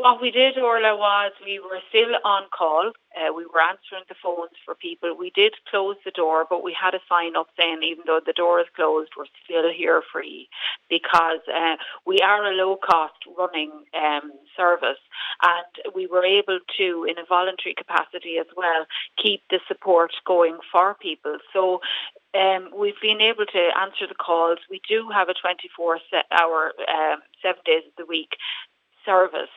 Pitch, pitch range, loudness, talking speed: 185 Hz, 170-205 Hz, -22 LUFS, 180 wpm